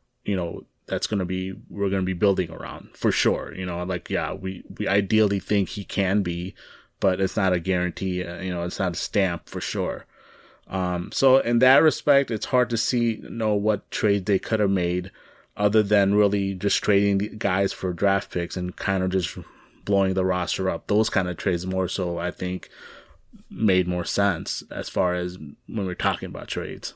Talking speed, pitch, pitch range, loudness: 205 wpm, 95 Hz, 90-105 Hz, -24 LUFS